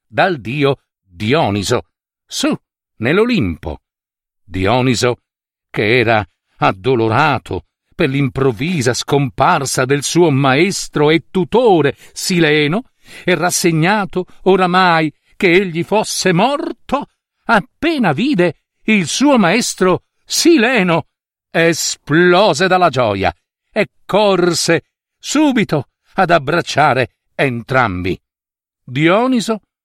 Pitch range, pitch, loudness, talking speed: 125-185 Hz, 160 Hz, -14 LUFS, 80 wpm